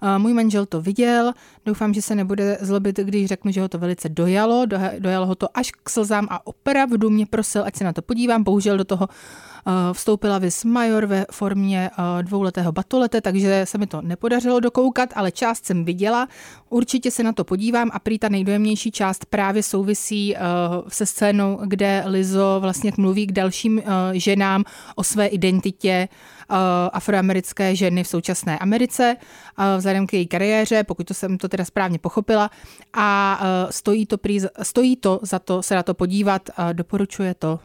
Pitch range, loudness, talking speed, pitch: 185-215 Hz, -20 LUFS, 170 wpm, 200 Hz